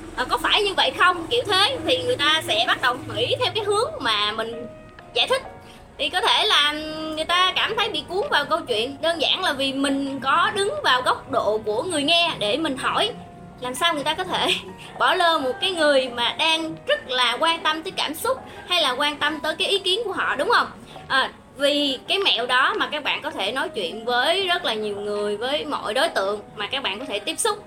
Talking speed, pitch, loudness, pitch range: 240 wpm, 315 Hz, -21 LUFS, 270-370 Hz